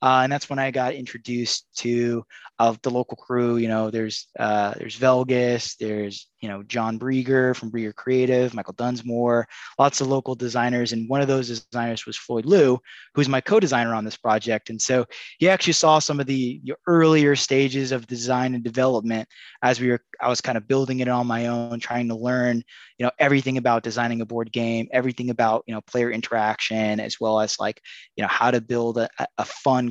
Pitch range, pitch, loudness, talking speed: 115-130 Hz, 120 Hz, -23 LUFS, 205 wpm